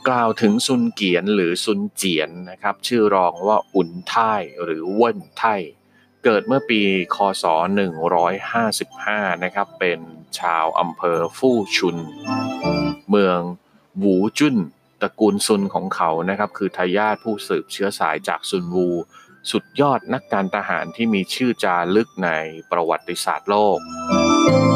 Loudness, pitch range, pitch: -20 LUFS, 90-115 Hz, 100 Hz